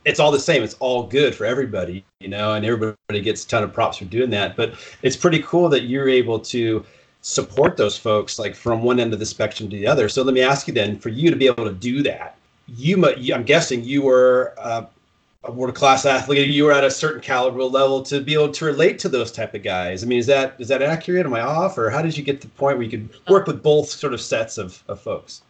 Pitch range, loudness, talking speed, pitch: 115-140 Hz, -19 LUFS, 270 wpm, 130 Hz